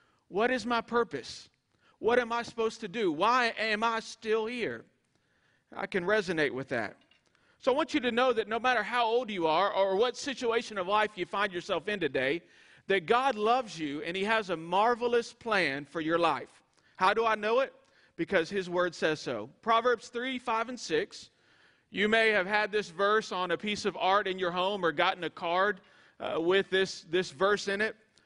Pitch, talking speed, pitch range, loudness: 210 Hz, 205 wpm, 185-235 Hz, -30 LUFS